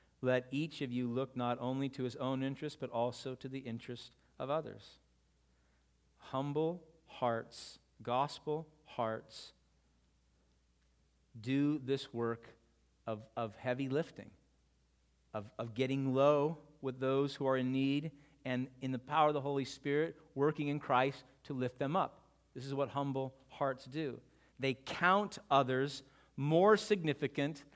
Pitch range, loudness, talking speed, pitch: 115-145 Hz, -37 LUFS, 140 wpm, 130 Hz